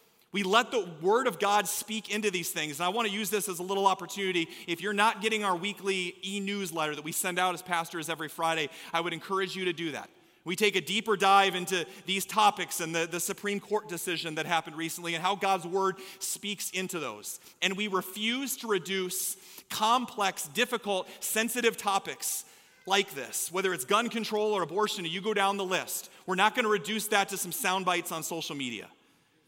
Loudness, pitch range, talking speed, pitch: -29 LUFS, 175-210 Hz, 205 wpm, 190 Hz